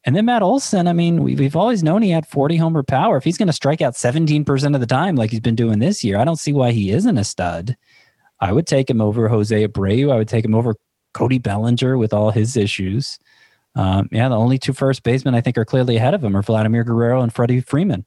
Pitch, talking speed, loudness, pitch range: 125 Hz, 250 wpm, -17 LUFS, 110-145 Hz